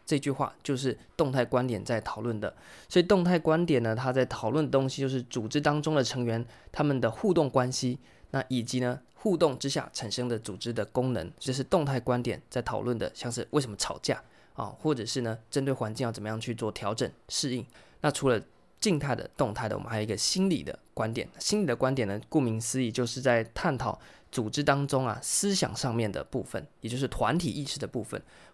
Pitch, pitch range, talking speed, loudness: 125 Hz, 115-145 Hz, 320 characters per minute, -30 LUFS